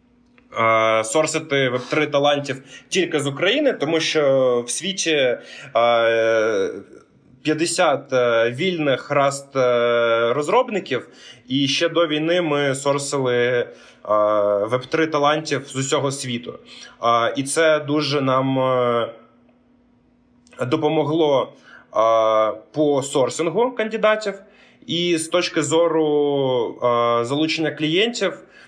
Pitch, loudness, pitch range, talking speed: 140 Hz, -20 LUFS, 120-160 Hz, 85 wpm